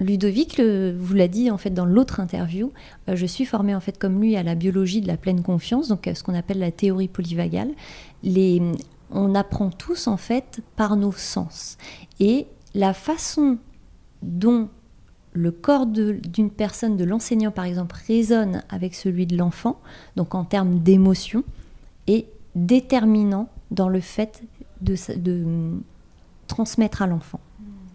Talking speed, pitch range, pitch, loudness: 160 wpm, 180-225 Hz, 200 Hz, -22 LUFS